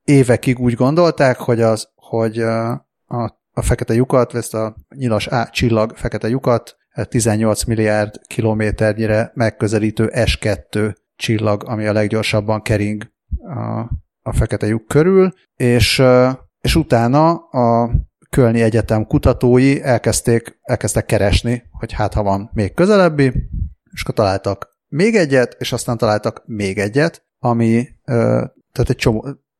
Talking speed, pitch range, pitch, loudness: 130 wpm, 110-125 Hz, 115 Hz, -16 LUFS